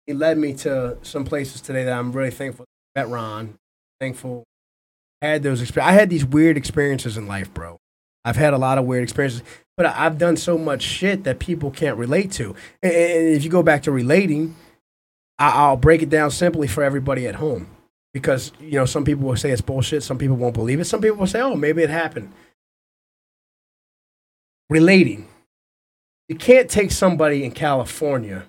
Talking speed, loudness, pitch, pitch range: 190 wpm, -19 LUFS, 140 Hz, 125-160 Hz